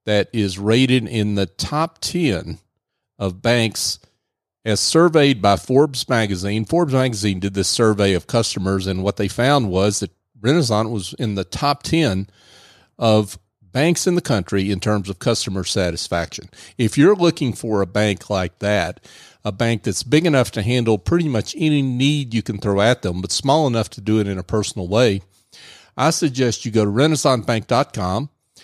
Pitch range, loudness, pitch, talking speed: 100-130 Hz, -19 LUFS, 110 Hz, 175 wpm